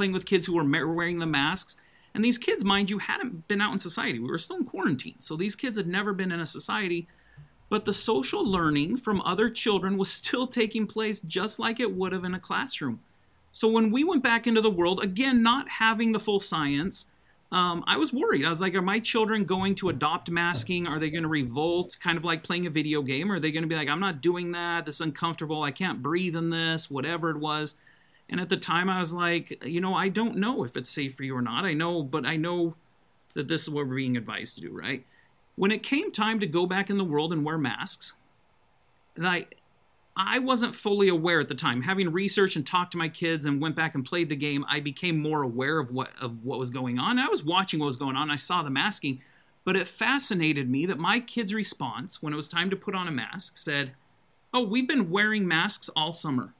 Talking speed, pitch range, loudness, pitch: 245 wpm, 155-205 Hz, -27 LUFS, 175 Hz